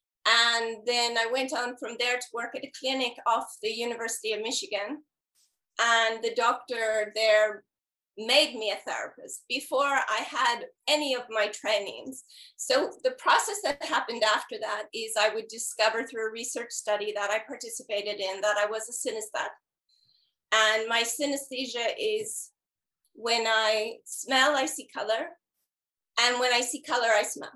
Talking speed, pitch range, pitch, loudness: 160 wpm, 220-270 Hz, 235 Hz, -27 LUFS